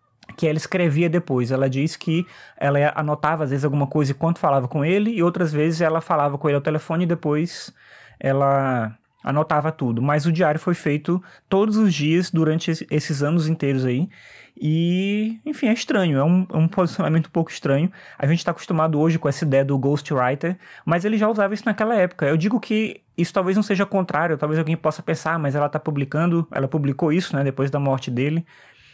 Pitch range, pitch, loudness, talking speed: 145-175 Hz, 160 Hz, -21 LUFS, 200 wpm